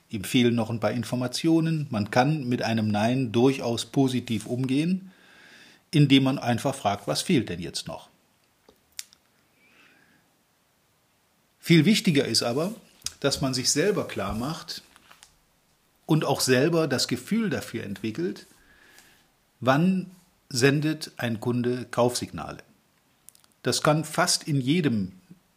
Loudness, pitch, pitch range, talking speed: -25 LUFS, 130 Hz, 115-155 Hz, 115 wpm